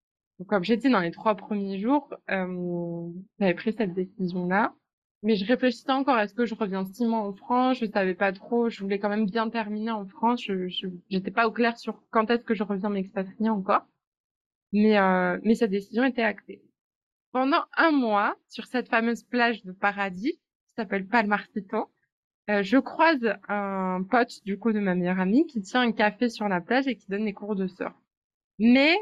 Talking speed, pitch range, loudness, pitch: 200 wpm, 195-235 Hz, -26 LUFS, 215 Hz